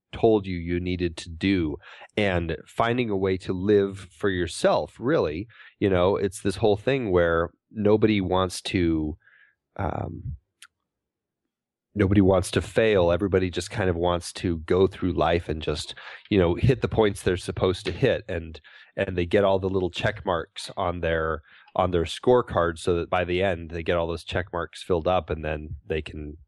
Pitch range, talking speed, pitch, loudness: 85-100 Hz, 185 wpm, 90 Hz, -25 LUFS